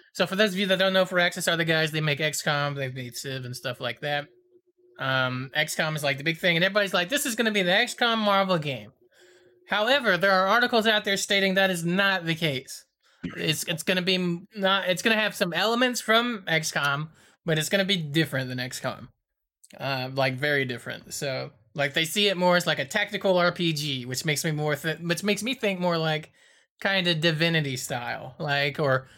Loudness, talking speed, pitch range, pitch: -25 LUFS, 225 wpm, 145-195 Hz, 170 Hz